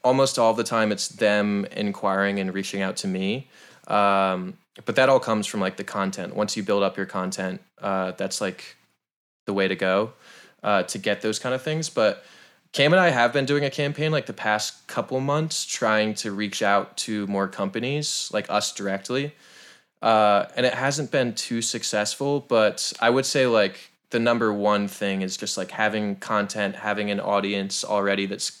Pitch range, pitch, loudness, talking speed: 100-125 Hz, 105 Hz, -24 LUFS, 190 wpm